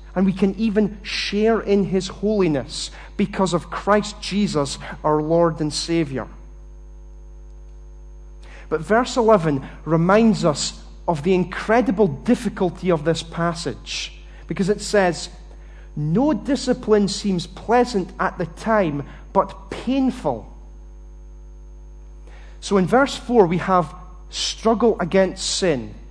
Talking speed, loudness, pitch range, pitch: 115 wpm, -21 LUFS, 150-205 Hz, 180 Hz